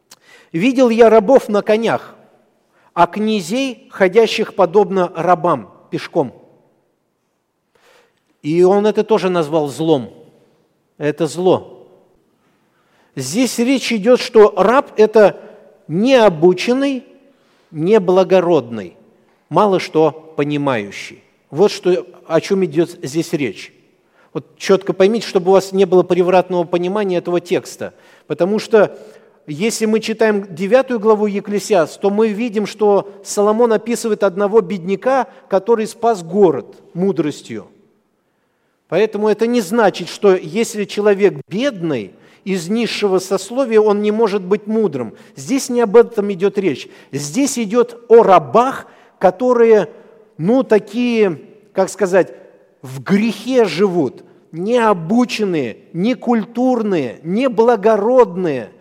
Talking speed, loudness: 110 wpm, -15 LUFS